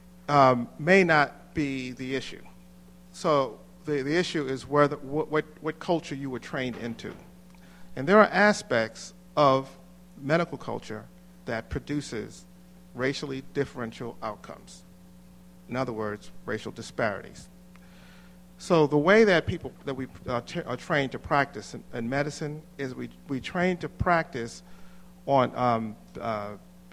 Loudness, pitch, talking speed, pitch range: -27 LUFS, 135 Hz, 140 wpm, 105-160 Hz